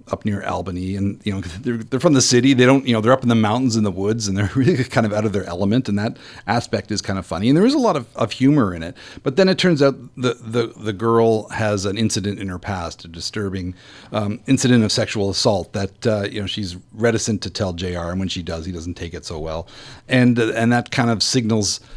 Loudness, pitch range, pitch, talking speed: -19 LUFS, 95-120 Hz, 110 Hz, 265 wpm